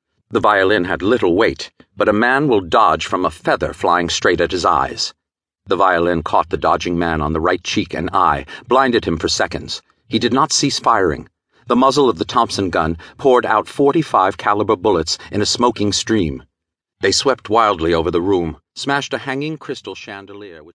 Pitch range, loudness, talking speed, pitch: 85-125 Hz, -16 LUFS, 190 wpm, 105 Hz